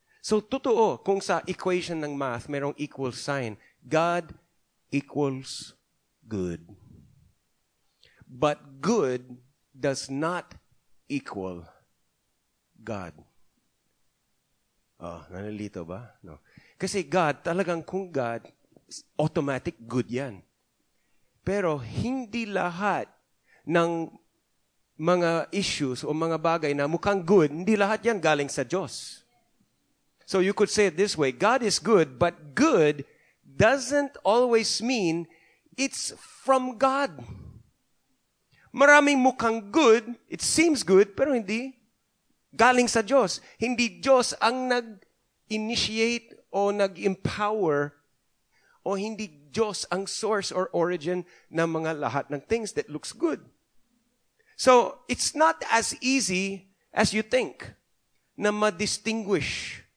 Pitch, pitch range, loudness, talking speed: 185 Hz, 145-225 Hz, -26 LUFS, 110 wpm